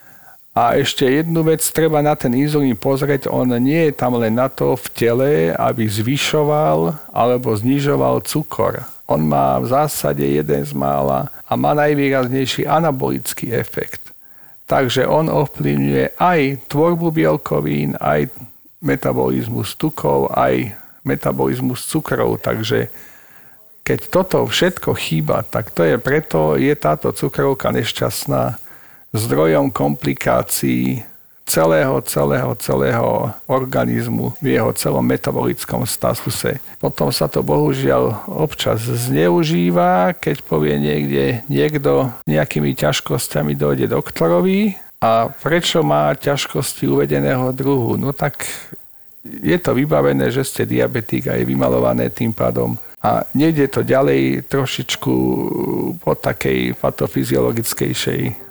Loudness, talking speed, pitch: -17 LUFS, 115 wpm, 75 Hz